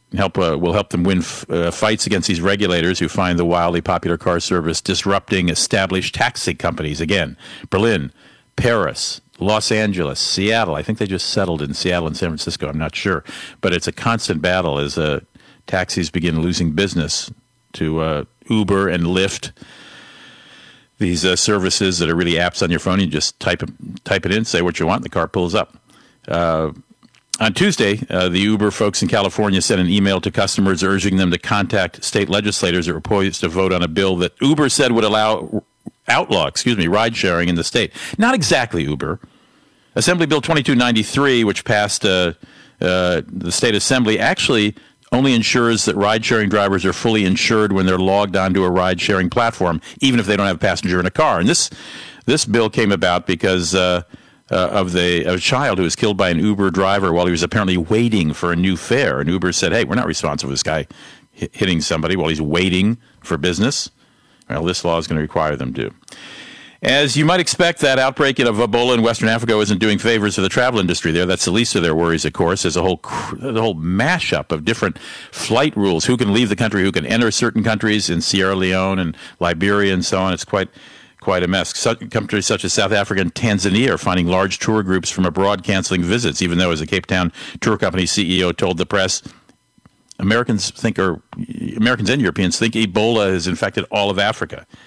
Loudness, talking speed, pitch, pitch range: -17 LUFS, 205 wpm, 95 Hz, 85-110 Hz